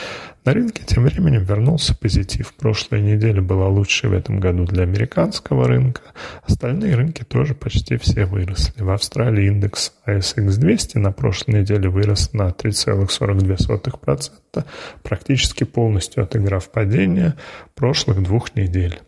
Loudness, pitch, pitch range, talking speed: -19 LUFS, 105 Hz, 95-120 Hz, 125 wpm